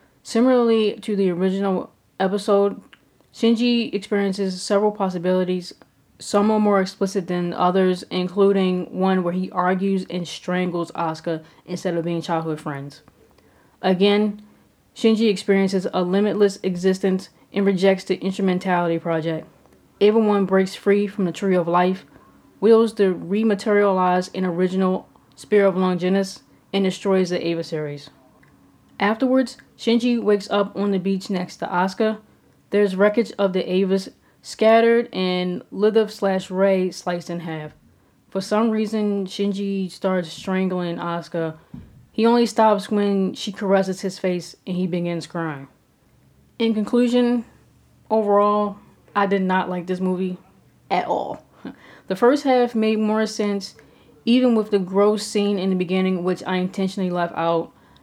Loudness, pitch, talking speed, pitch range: -21 LUFS, 195 Hz, 140 wpm, 180-205 Hz